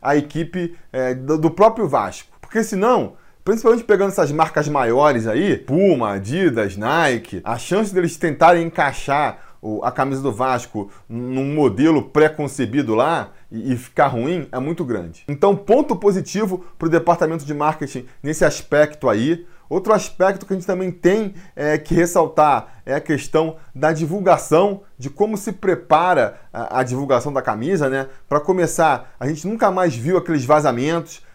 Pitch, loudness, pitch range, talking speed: 160 Hz, -19 LUFS, 135-185 Hz, 155 wpm